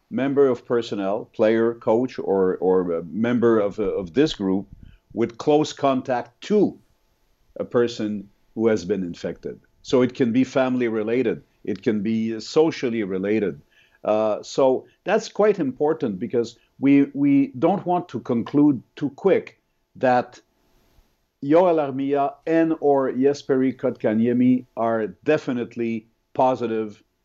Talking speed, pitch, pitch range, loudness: 125 wpm, 125 Hz, 110-140 Hz, -22 LUFS